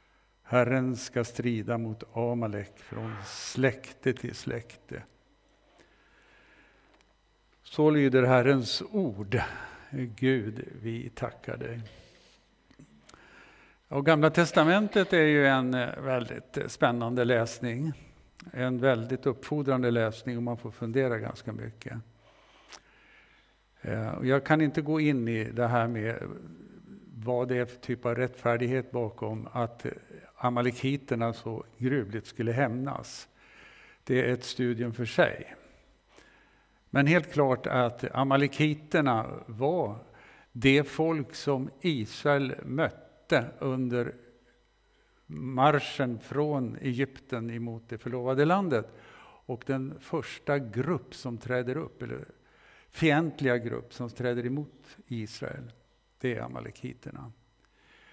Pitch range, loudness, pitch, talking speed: 120-140 Hz, -29 LUFS, 125 Hz, 105 wpm